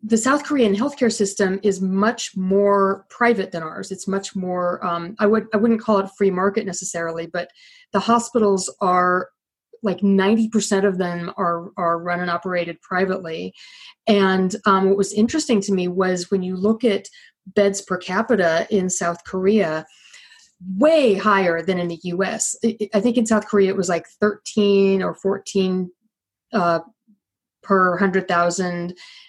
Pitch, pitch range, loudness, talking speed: 195 Hz, 180-215 Hz, -20 LUFS, 155 wpm